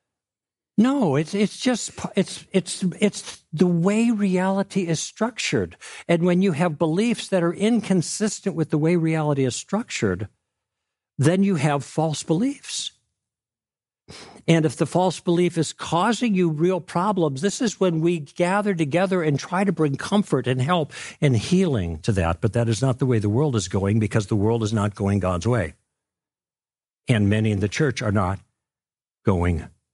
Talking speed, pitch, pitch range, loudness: 170 wpm, 160 Hz, 120-190 Hz, -22 LUFS